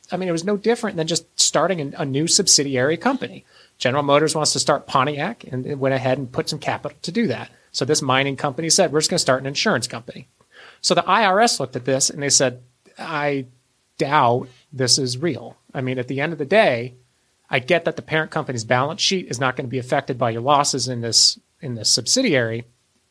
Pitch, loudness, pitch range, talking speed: 145 Hz, -19 LUFS, 130-160 Hz, 225 wpm